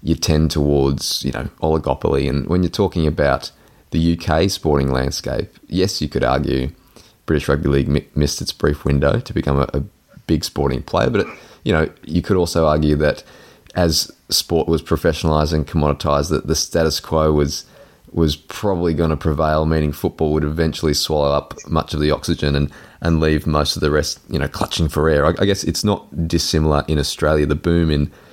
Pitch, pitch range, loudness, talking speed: 75 Hz, 75-85 Hz, -19 LUFS, 195 wpm